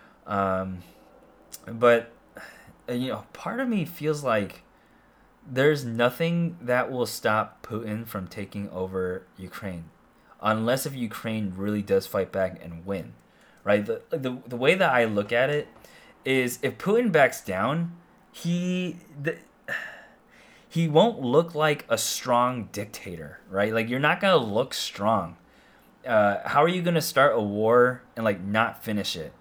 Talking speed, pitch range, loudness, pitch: 145 wpm, 100-155 Hz, -25 LUFS, 120 Hz